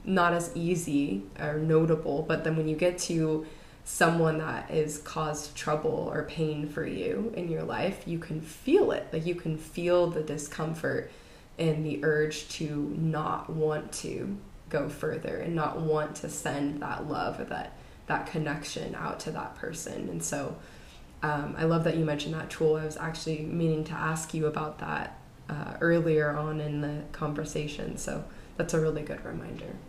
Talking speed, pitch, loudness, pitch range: 175 wpm, 155 Hz, -31 LUFS, 150-165 Hz